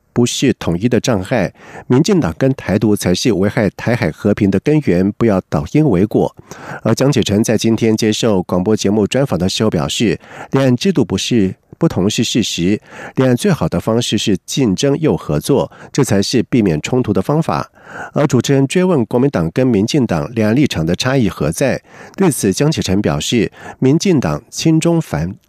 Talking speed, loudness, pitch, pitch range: 280 characters per minute, -15 LUFS, 120 Hz, 100-135 Hz